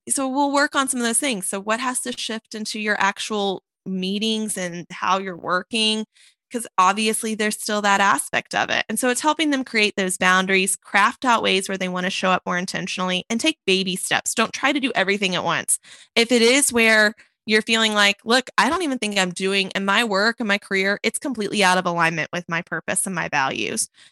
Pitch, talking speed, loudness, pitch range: 210 Hz, 225 wpm, -20 LUFS, 190-230 Hz